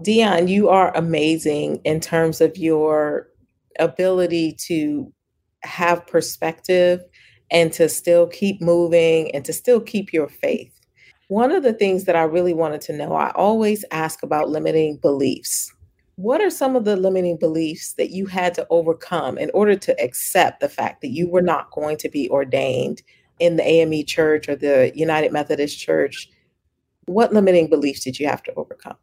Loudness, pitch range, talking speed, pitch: -19 LUFS, 160-200 Hz, 170 wpm, 170 Hz